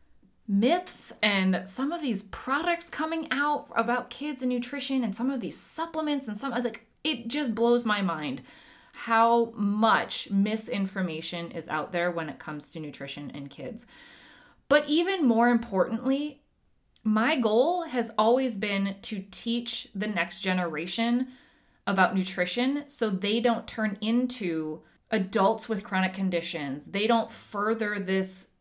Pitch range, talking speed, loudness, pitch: 190-255 Hz, 140 wpm, -28 LUFS, 225 Hz